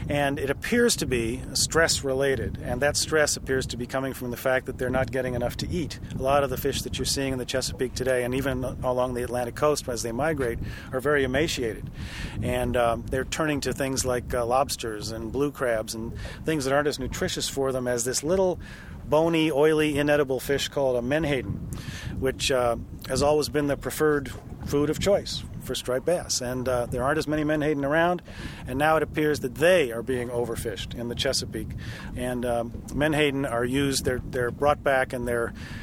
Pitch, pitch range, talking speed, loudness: 130 Hz, 120-145 Hz, 205 wpm, -26 LUFS